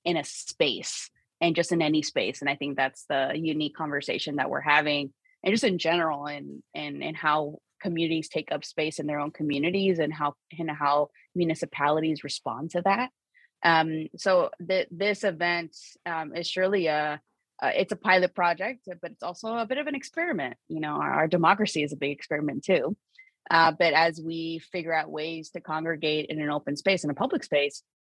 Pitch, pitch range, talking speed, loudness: 160 Hz, 150-180 Hz, 200 wpm, -27 LUFS